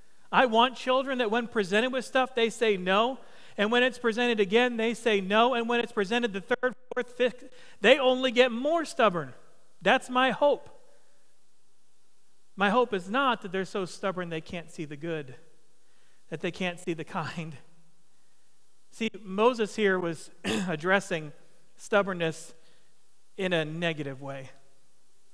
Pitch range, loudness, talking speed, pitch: 170-245 Hz, -27 LUFS, 150 wpm, 205 Hz